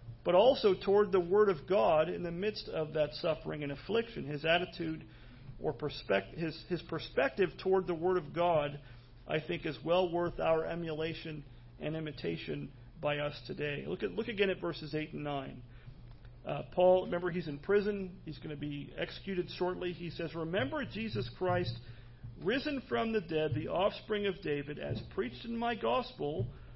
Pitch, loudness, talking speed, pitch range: 160 Hz, -34 LUFS, 175 wpm, 145-185 Hz